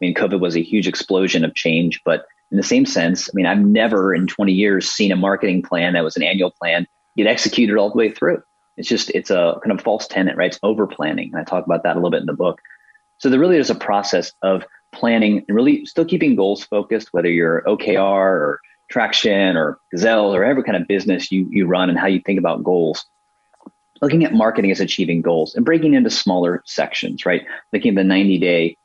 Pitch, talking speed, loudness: 100 Hz, 230 wpm, -17 LUFS